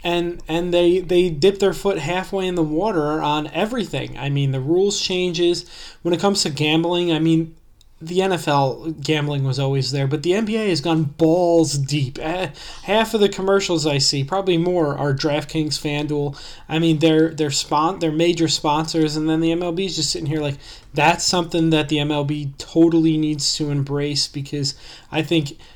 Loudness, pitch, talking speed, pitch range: -20 LUFS, 160 Hz, 180 wpm, 150-175 Hz